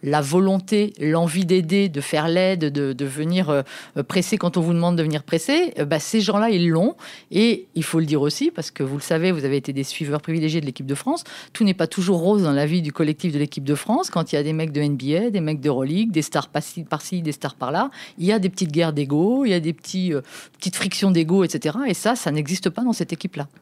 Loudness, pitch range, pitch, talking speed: -21 LUFS, 150-190 Hz, 165 Hz, 265 wpm